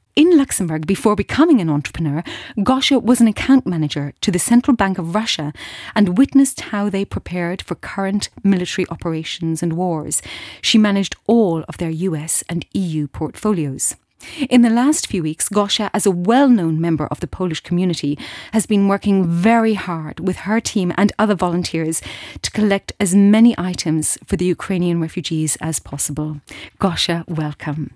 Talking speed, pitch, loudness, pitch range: 165 wpm, 185 Hz, -17 LUFS, 160-215 Hz